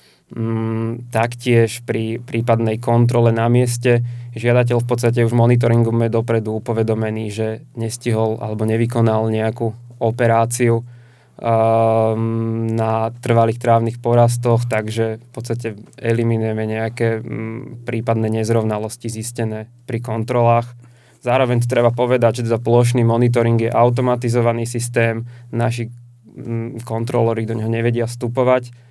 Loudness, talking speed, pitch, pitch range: -18 LUFS, 110 wpm, 115 Hz, 115-120 Hz